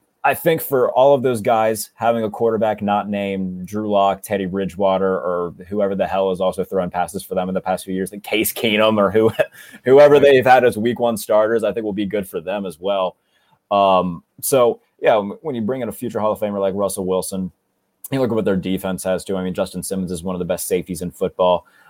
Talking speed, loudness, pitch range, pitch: 240 wpm, -19 LUFS, 95-110 Hz, 100 Hz